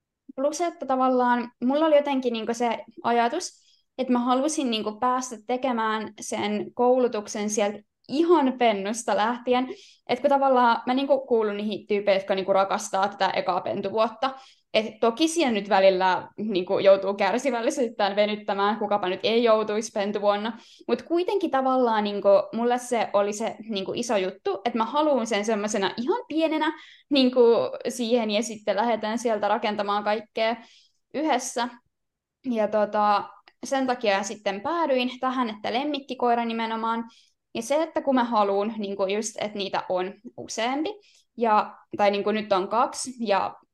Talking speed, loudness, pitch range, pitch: 150 wpm, -25 LUFS, 205-260 Hz, 230 Hz